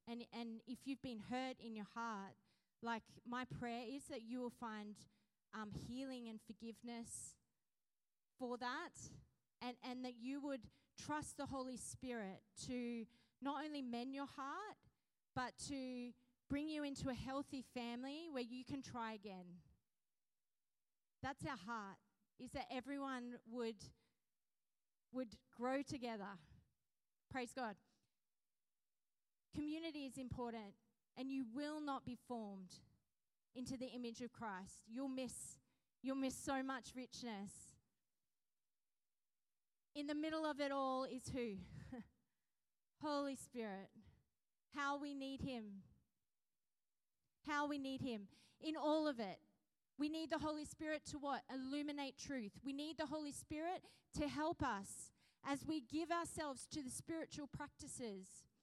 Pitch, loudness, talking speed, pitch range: 255 Hz, -48 LUFS, 135 wpm, 230-285 Hz